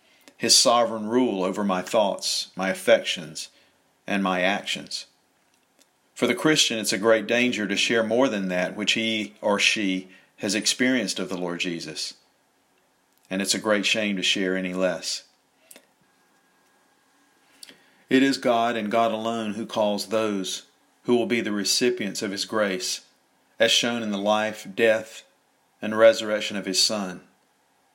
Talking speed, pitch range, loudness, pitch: 150 wpm, 95-115 Hz, -23 LUFS, 110 Hz